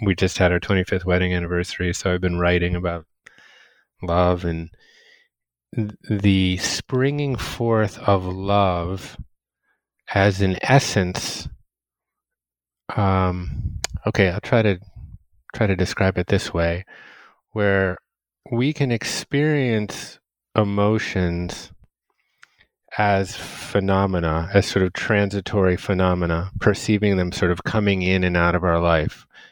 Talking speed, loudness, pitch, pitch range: 115 wpm, -21 LUFS, 95 Hz, 90-105 Hz